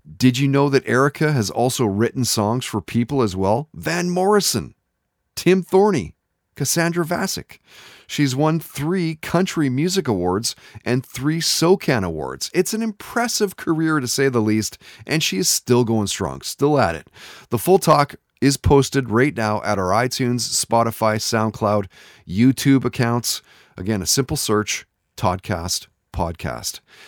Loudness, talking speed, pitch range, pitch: -20 LUFS, 145 wpm, 110-155 Hz, 125 Hz